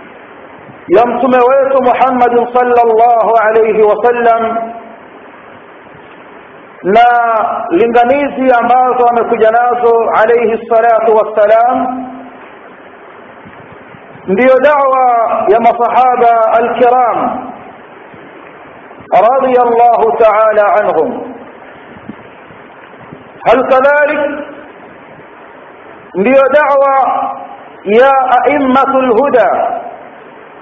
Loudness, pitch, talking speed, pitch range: -9 LUFS, 245 Hz, 55 wpm, 230-270 Hz